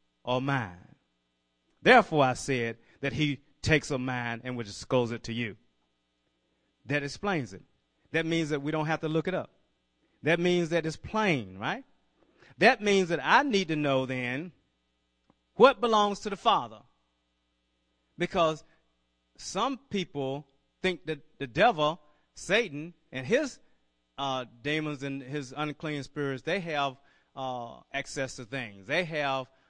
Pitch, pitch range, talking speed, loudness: 140 Hz, 110-160 Hz, 145 wpm, -29 LUFS